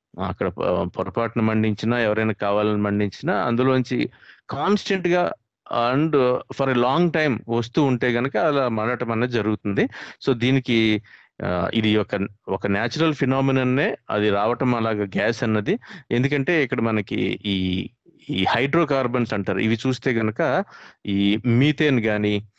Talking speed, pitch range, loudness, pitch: 120 wpm, 105-130 Hz, -22 LUFS, 115 Hz